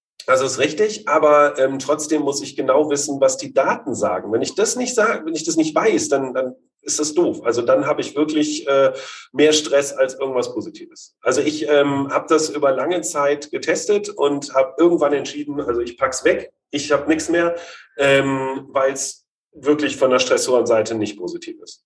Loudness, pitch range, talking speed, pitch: -19 LUFS, 140-170 Hz, 200 wpm, 145 Hz